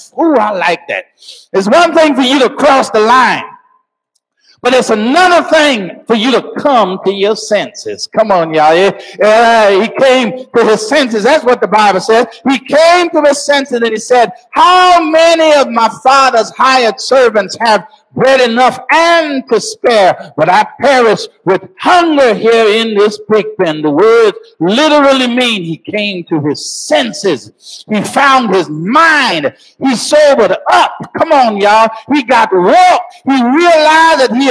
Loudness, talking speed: -9 LUFS, 165 wpm